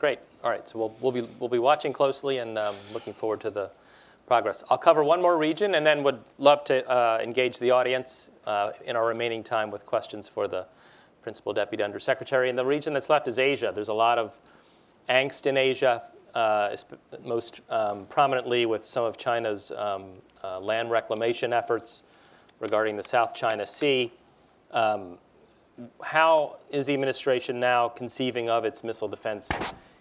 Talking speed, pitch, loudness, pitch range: 175 wpm, 120 Hz, -26 LUFS, 110-135 Hz